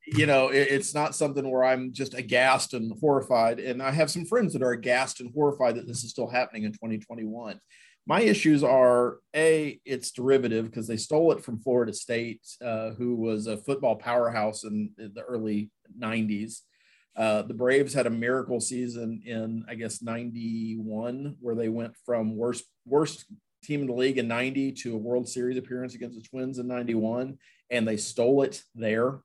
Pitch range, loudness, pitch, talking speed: 115-135 Hz, -27 LUFS, 125 Hz, 185 wpm